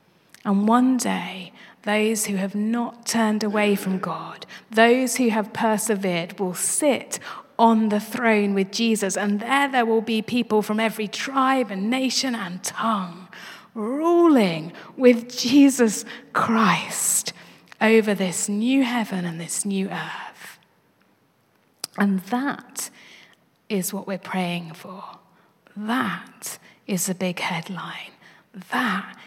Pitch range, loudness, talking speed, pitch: 190-235 Hz, -22 LUFS, 125 wpm, 215 Hz